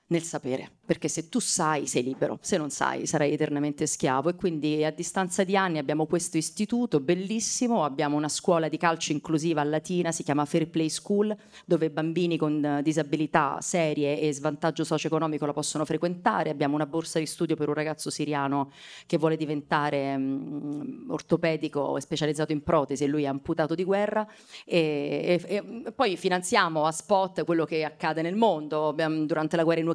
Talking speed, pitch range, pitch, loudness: 180 wpm, 150-175 Hz, 160 Hz, -27 LUFS